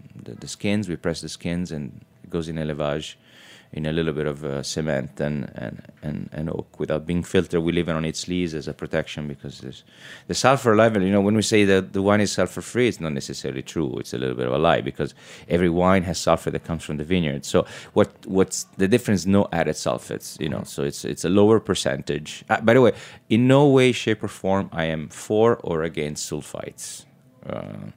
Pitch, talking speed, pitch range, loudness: 85 Hz, 225 wpm, 75-100 Hz, -23 LUFS